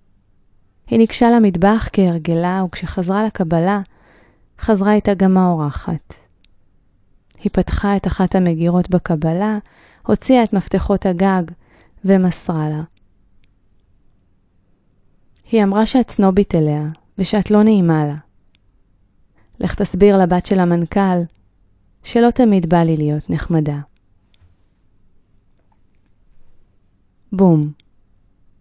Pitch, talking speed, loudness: 165 Hz, 90 wpm, -16 LUFS